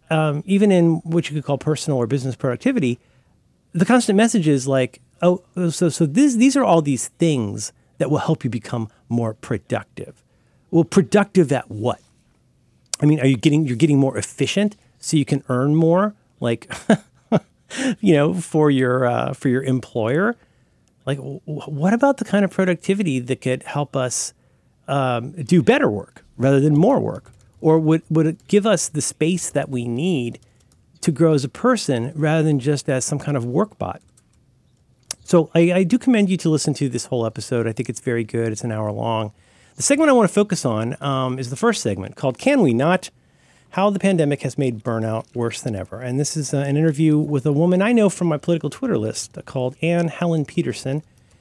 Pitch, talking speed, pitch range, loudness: 145 Hz, 200 wpm, 130-175 Hz, -20 LUFS